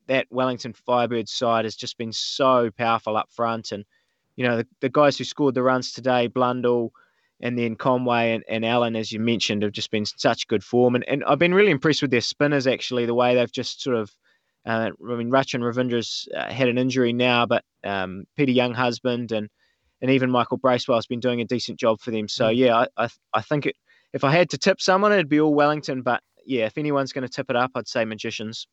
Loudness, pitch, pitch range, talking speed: -22 LUFS, 125 Hz, 115-130 Hz, 235 wpm